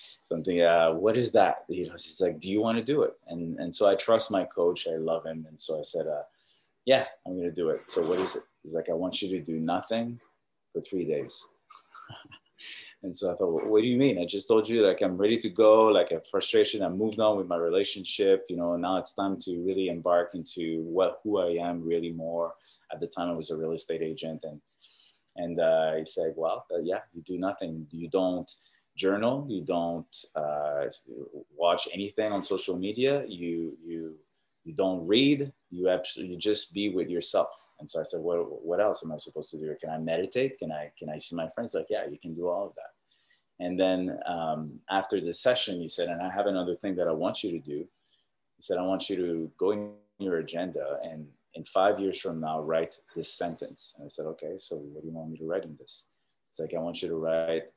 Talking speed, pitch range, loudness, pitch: 235 wpm, 80-100 Hz, -29 LUFS, 85 Hz